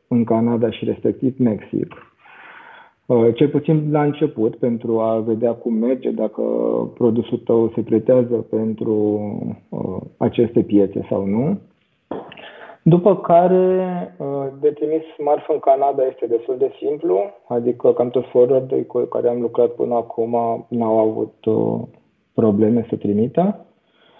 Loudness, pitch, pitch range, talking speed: -19 LUFS, 120 Hz, 115-155 Hz, 125 wpm